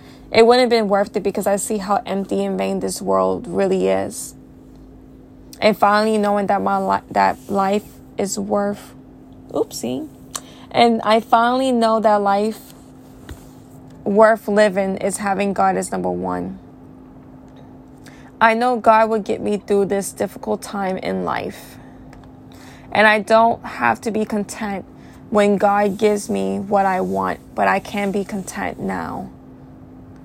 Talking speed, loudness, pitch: 145 wpm, -18 LUFS, 200 Hz